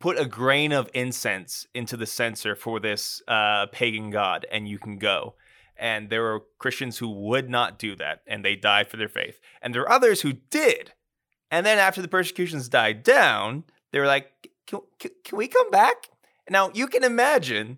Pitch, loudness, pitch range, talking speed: 130 Hz, -23 LUFS, 110-180 Hz, 195 wpm